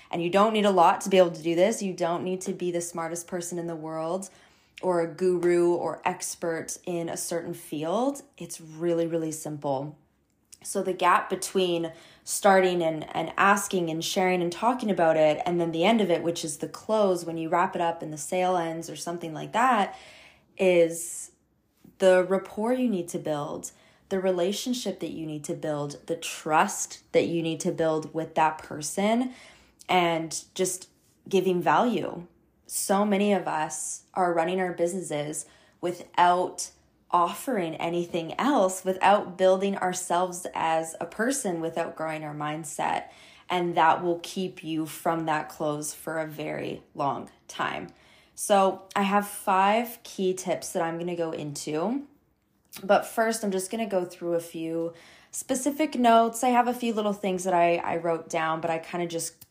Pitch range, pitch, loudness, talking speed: 165-190 Hz, 175 Hz, -27 LUFS, 175 wpm